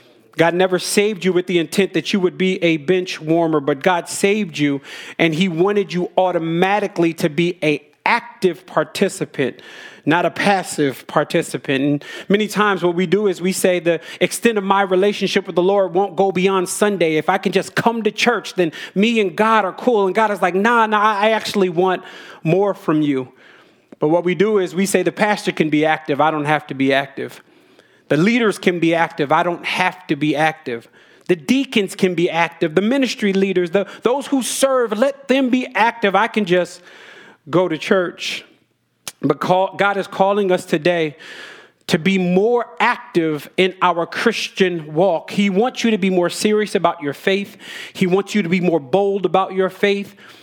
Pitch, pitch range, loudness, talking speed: 185 Hz, 170-205 Hz, -18 LUFS, 195 wpm